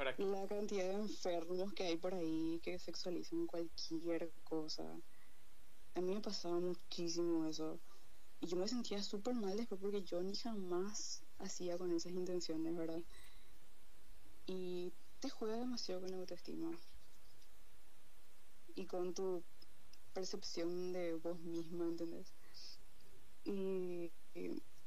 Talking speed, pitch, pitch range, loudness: 120 wpm, 180 Hz, 170-195 Hz, -44 LUFS